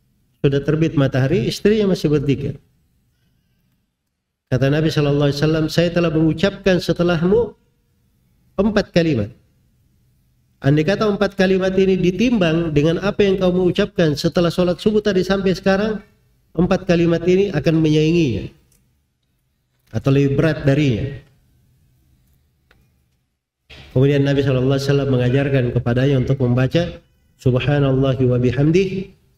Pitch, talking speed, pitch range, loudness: 155 Hz, 110 wpm, 135-185 Hz, -17 LUFS